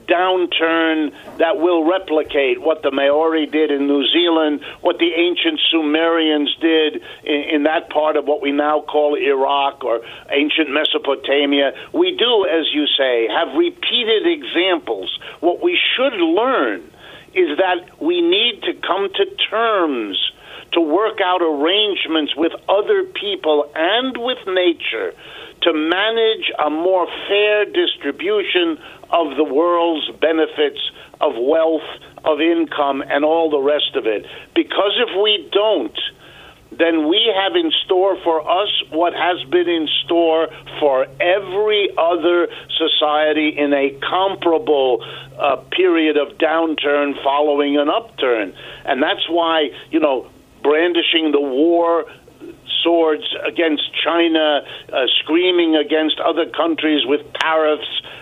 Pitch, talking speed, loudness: 165 Hz, 130 wpm, -17 LUFS